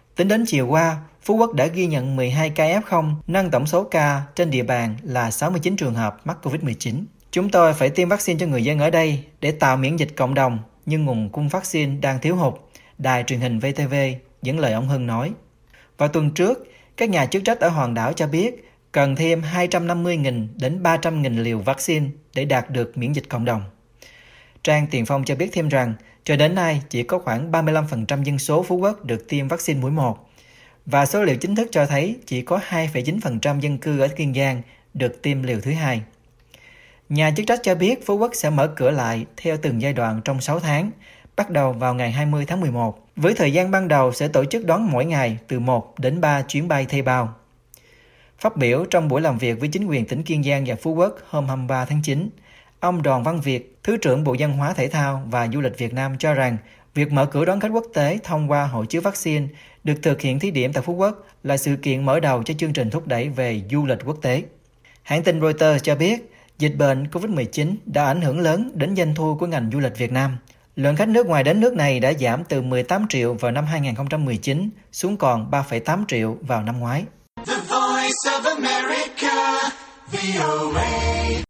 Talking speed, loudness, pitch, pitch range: 210 wpm, -21 LUFS, 145 Hz, 125-165 Hz